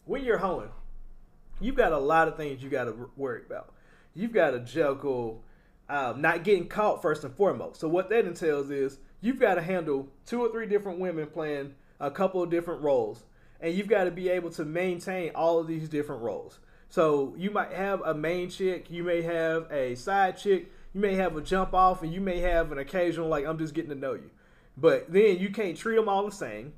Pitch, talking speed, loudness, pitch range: 170 Hz, 220 wpm, -28 LUFS, 155-190 Hz